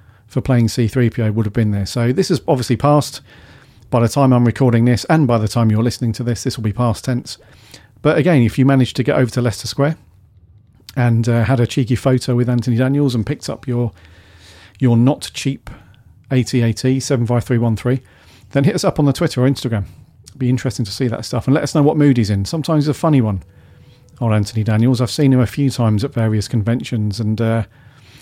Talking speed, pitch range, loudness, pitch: 230 wpm, 110-130 Hz, -17 LUFS, 120 Hz